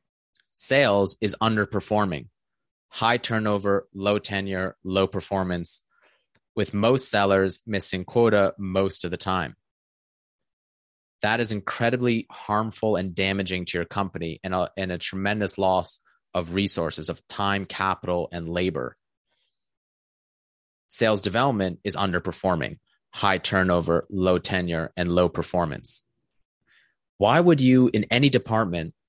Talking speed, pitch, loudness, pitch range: 120 wpm, 95 Hz, -24 LUFS, 90-105 Hz